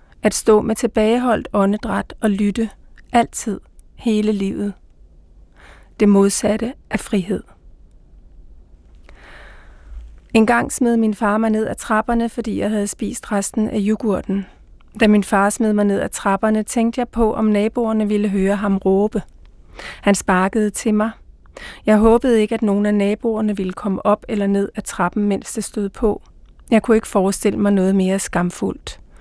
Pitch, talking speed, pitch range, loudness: 205 Hz, 160 wpm, 190-220 Hz, -18 LUFS